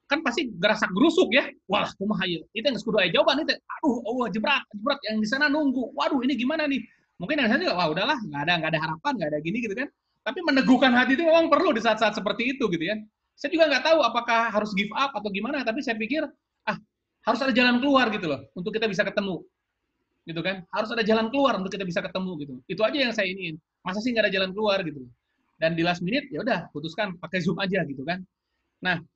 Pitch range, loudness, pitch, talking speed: 190-275 Hz, -25 LUFS, 220 Hz, 235 wpm